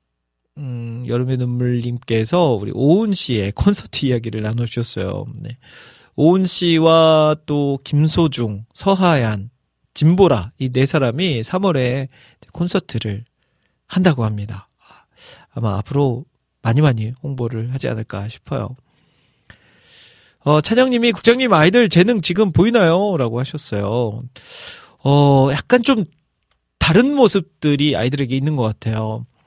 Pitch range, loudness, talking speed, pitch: 115-165 Hz, -17 LUFS, 255 characters per minute, 135 Hz